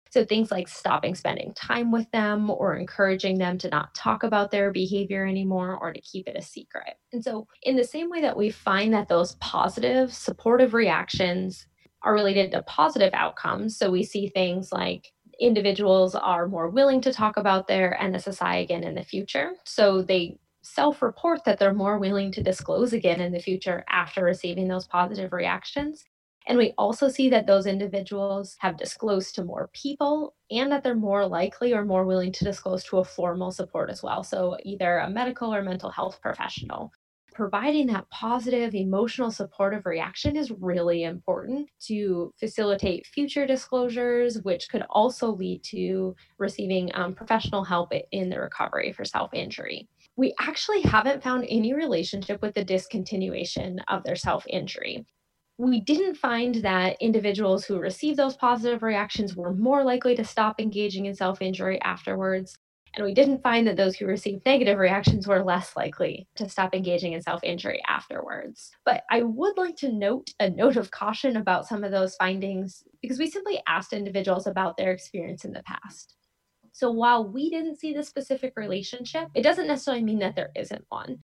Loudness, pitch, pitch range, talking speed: -26 LUFS, 200 Hz, 185-245 Hz, 175 wpm